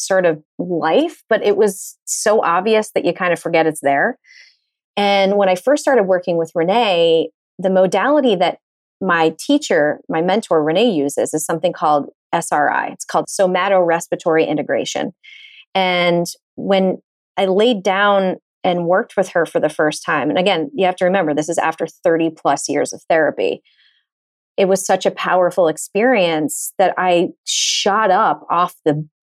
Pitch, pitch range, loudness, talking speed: 180 Hz, 165-195 Hz, -17 LUFS, 165 wpm